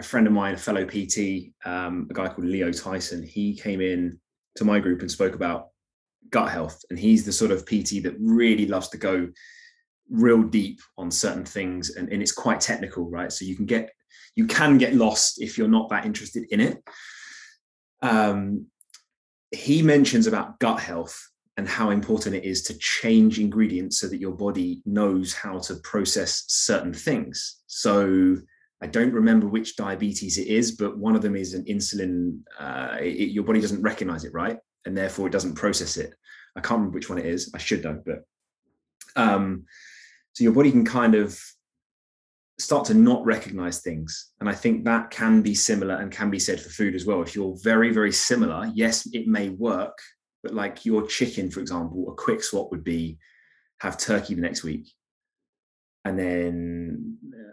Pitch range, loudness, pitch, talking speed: 95-115 Hz, -24 LUFS, 105 Hz, 185 wpm